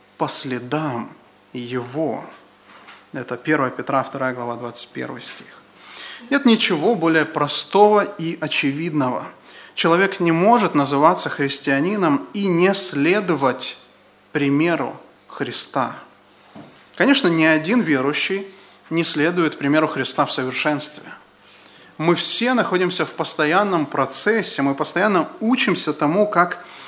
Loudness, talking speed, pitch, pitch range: -18 LUFS, 105 wpm, 160 Hz, 140-190 Hz